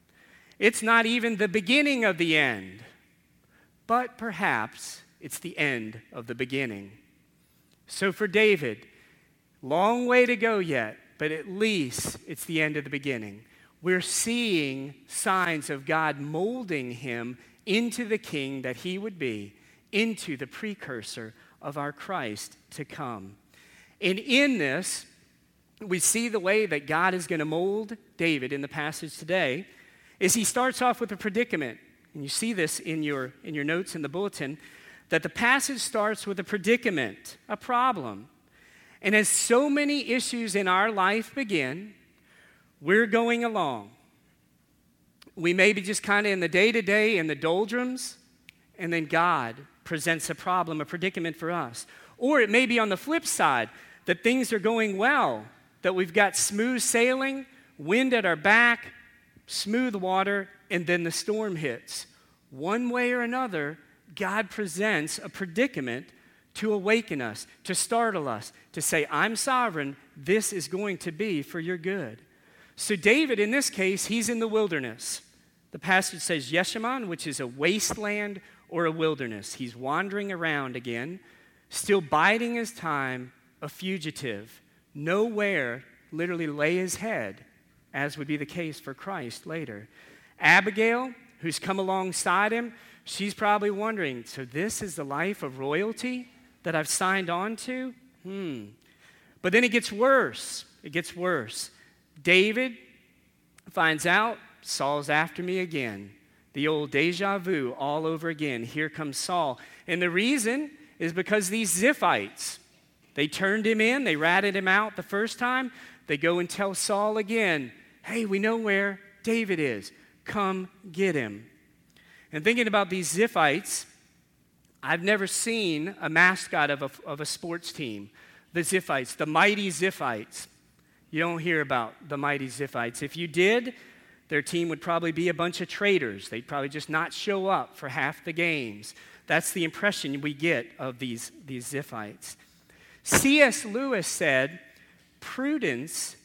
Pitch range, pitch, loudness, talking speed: 150-215 Hz, 185 Hz, -27 LUFS, 155 wpm